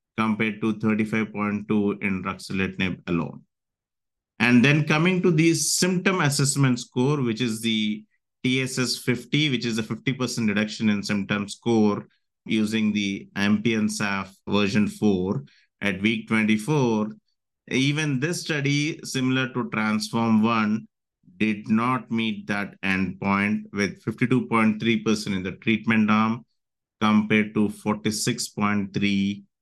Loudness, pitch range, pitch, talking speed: -24 LUFS, 105-125 Hz, 110 Hz, 115 wpm